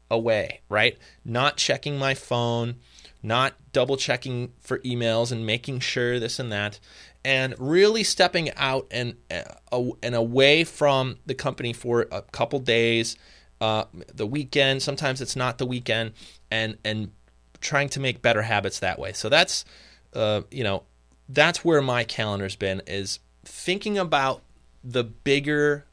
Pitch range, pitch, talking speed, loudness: 105-135 Hz, 120 Hz, 150 wpm, -24 LUFS